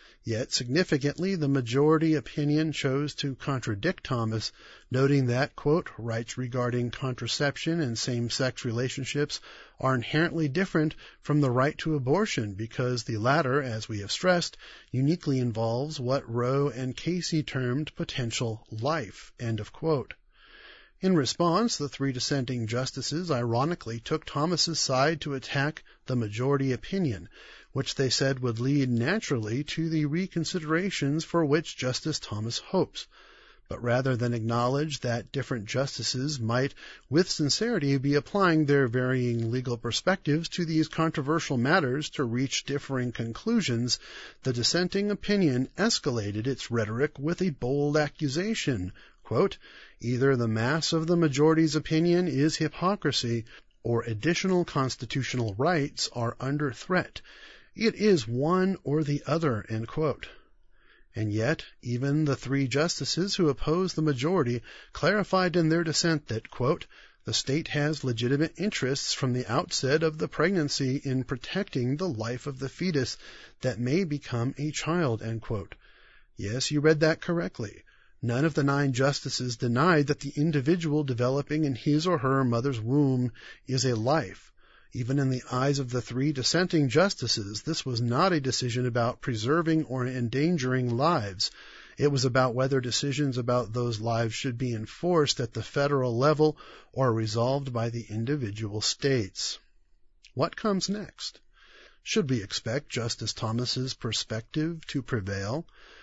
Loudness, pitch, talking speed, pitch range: -28 LUFS, 140 Hz, 140 wpm, 125-155 Hz